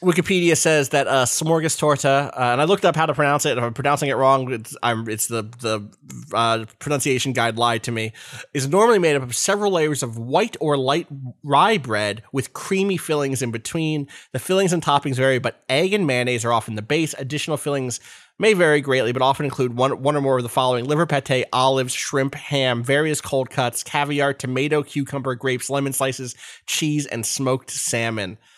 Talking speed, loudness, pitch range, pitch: 195 wpm, -20 LUFS, 125-150 Hz, 135 Hz